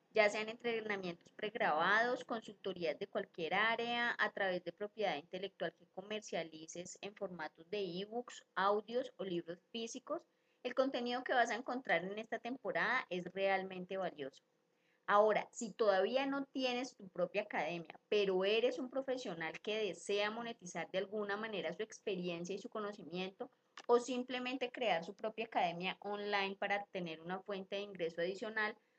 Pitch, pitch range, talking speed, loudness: 205 Hz, 180-235 Hz, 150 wpm, -39 LUFS